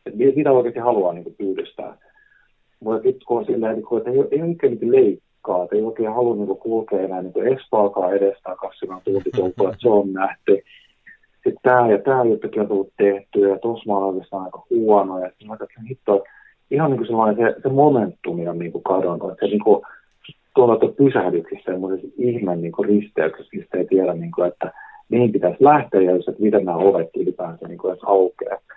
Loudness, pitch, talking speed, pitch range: -19 LUFS, 110 Hz, 150 wpm, 95-140 Hz